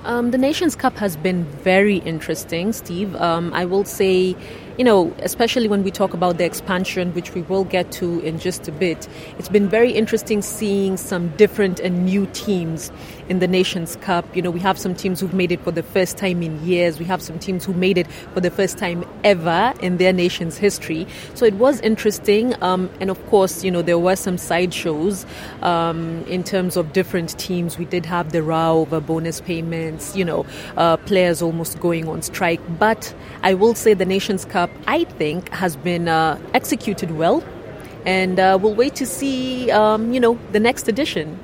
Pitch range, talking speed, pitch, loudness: 170-205 Hz, 200 wpm, 185 Hz, -19 LUFS